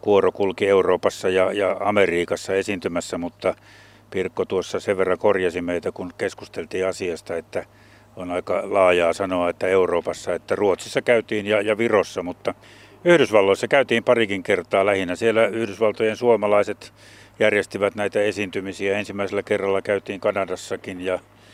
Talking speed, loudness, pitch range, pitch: 125 wpm, -22 LUFS, 95-110 Hz, 100 Hz